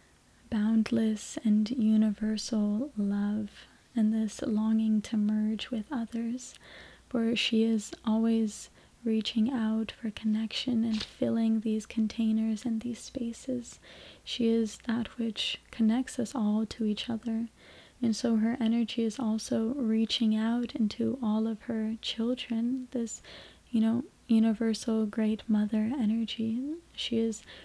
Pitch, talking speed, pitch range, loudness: 225 Hz, 125 wpm, 220-235 Hz, -30 LUFS